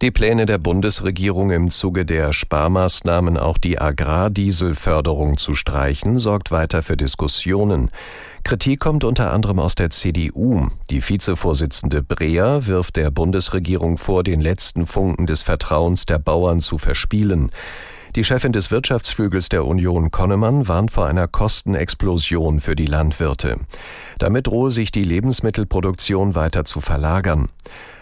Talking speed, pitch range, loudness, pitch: 135 wpm, 80-100 Hz, -18 LUFS, 90 Hz